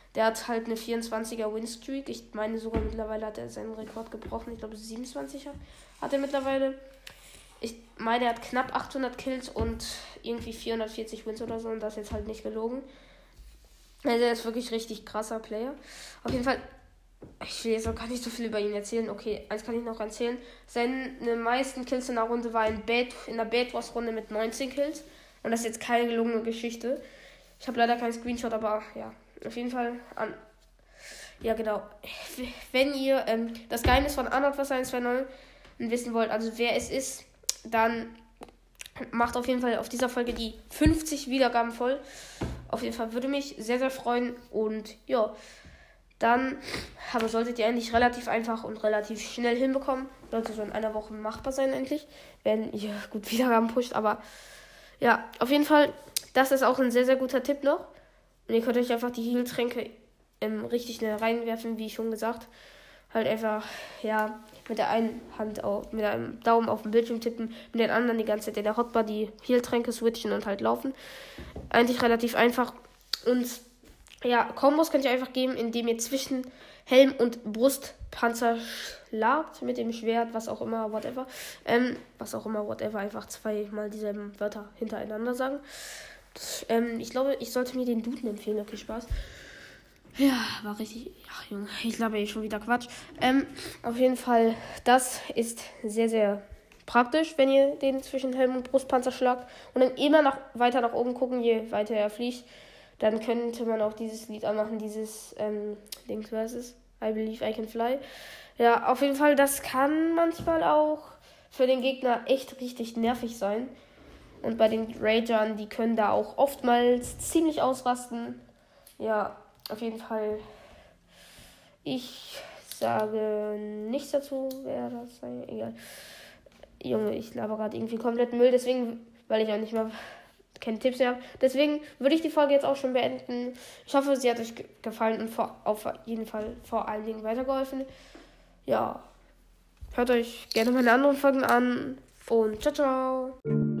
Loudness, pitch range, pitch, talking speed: -29 LUFS, 220-260 Hz, 235 Hz, 175 wpm